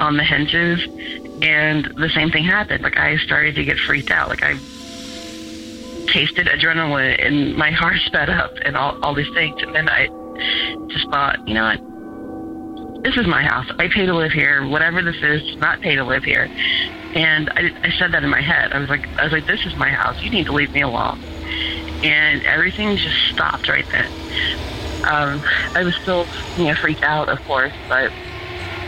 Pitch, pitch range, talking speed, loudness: 155 Hz, 135-170 Hz, 195 wpm, -17 LUFS